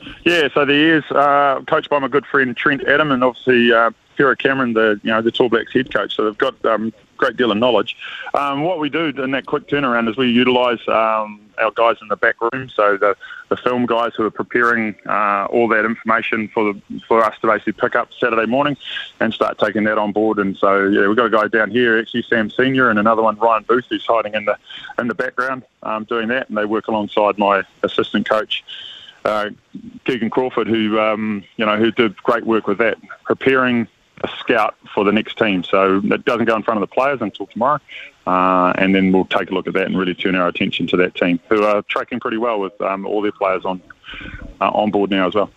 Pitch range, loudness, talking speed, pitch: 105-125 Hz, -17 LUFS, 235 wpm, 110 Hz